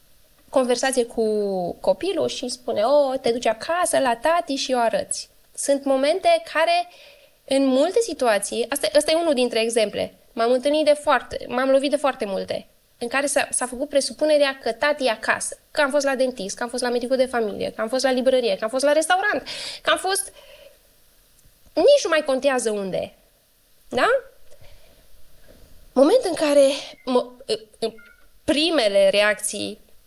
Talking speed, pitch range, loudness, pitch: 170 wpm, 245-305 Hz, -21 LUFS, 275 Hz